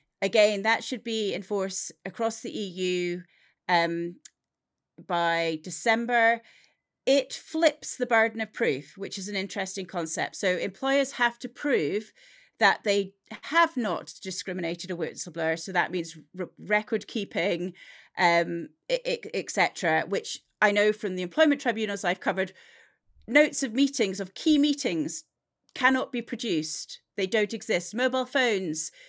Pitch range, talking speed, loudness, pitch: 180-250 Hz, 135 wpm, -27 LUFS, 205 Hz